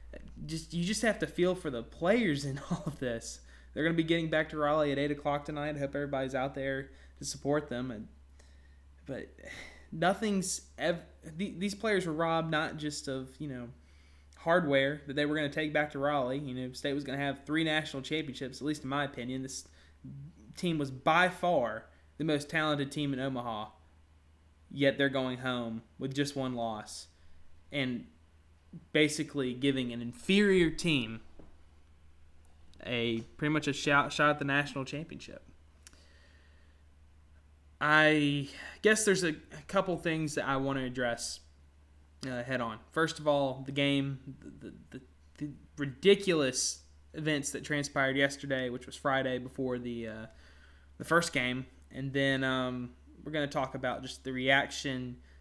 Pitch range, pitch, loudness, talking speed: 105-150 Hz, 135 Hz, -32 LUFS, 160 wpm